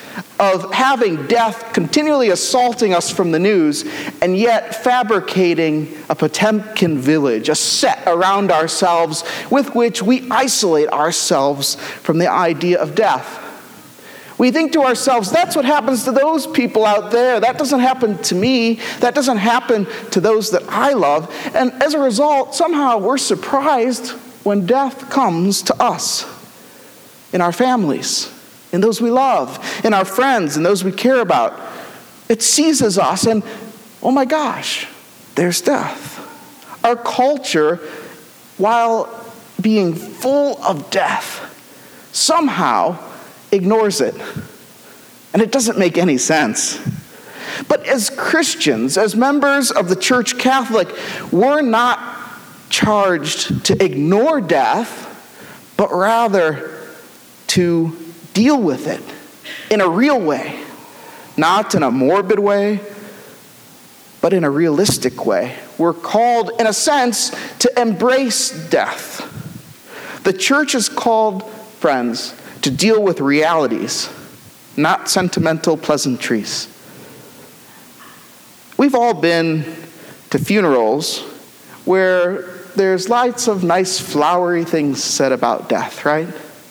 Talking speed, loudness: 120 wpm, -16 LUFS